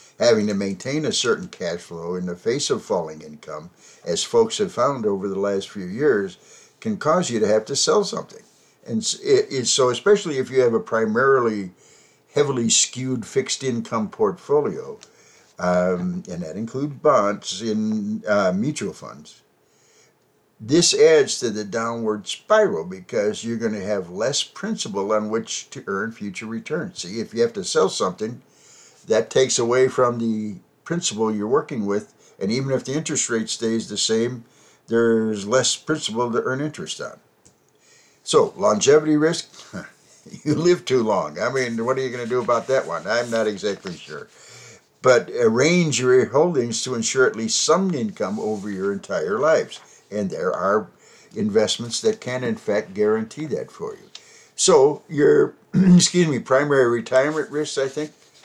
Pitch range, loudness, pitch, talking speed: 110-175 Hz, -21 LUFS, 125 Hz, 165 wpm